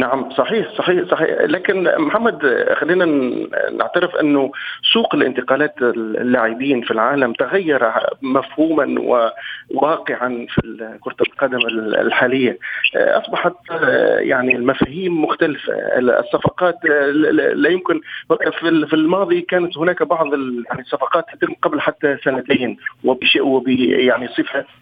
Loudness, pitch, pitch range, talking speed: -17 LUFS, 145 Hz, 125-175 Hz, 100 wpm